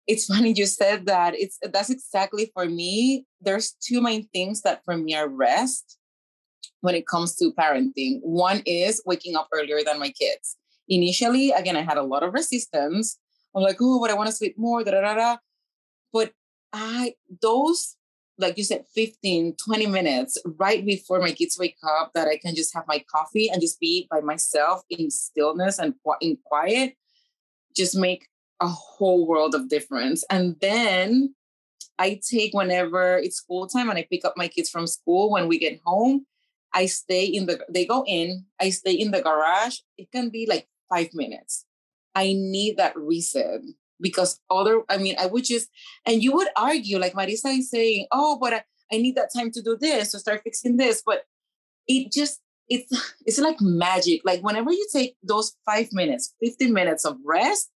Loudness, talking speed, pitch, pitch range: -23 LUFS, 190 wpm, 205 Hz, 180-245 Hz